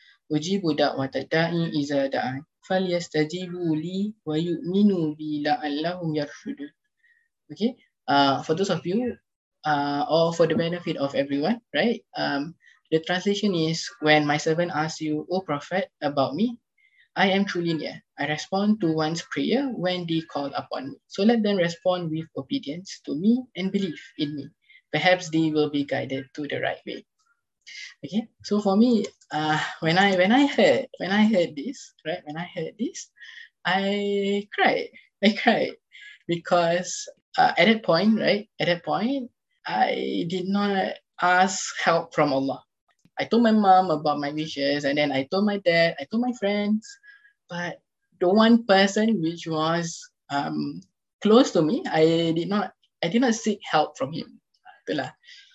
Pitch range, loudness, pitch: 155-225 Hz, -24 LUFS, 180 Hz